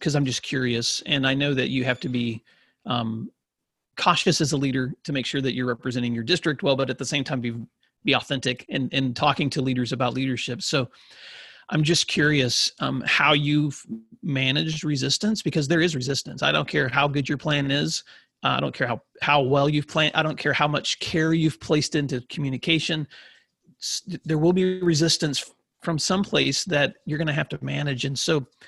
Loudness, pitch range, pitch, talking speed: -23 LUFS, 130-155 Hz, 145 Hz, 200 wpm